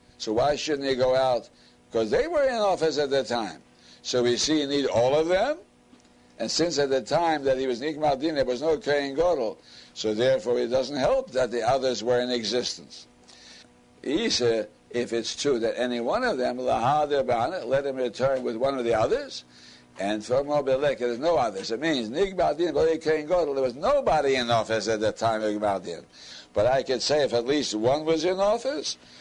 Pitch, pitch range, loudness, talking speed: 130 Hz, 110-150 Hz, -25 LUFS, 195 wpm